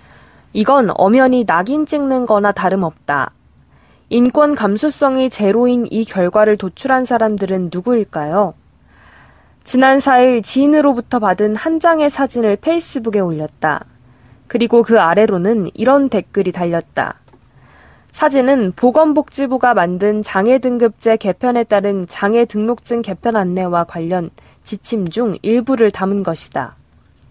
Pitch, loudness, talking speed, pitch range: 220 Hz, -15 LUFS, 275 characters per minute, 185-255 Hz